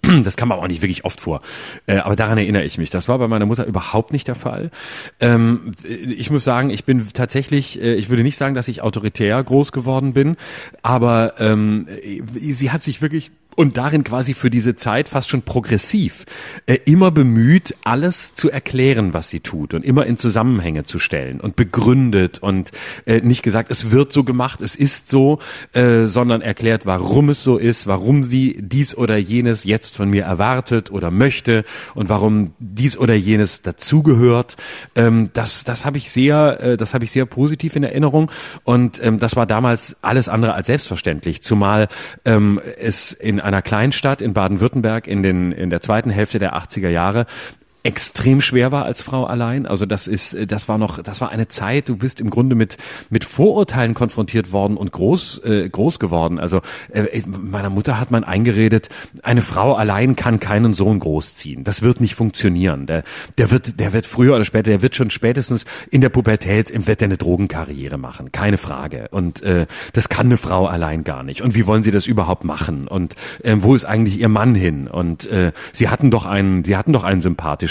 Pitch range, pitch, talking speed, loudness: 100-130 Hz, 115 Hz, 195 wpm, -17 LUFS